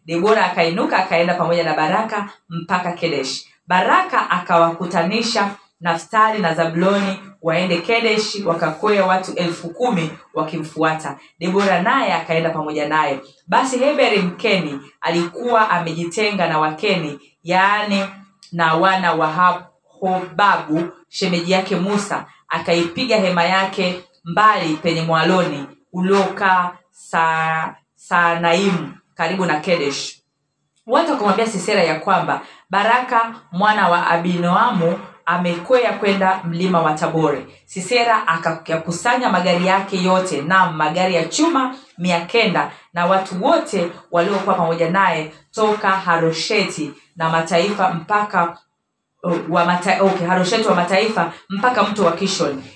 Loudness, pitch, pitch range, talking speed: -18 LUFS, 180 Hz, 165-195 Hz, 115 wpm